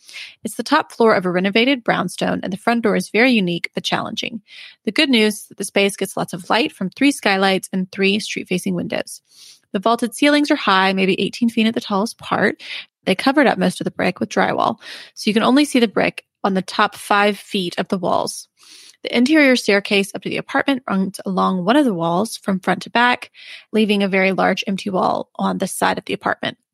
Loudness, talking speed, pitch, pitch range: -18 LUFS, 225 wpm, 210 Hz, 195-245 Hz